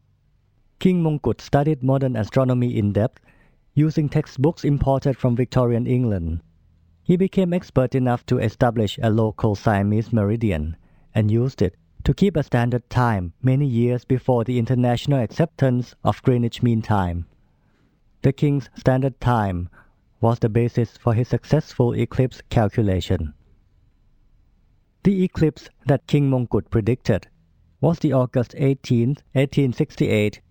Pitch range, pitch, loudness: 105-135 Hz, 120 Hz, -21 LUFS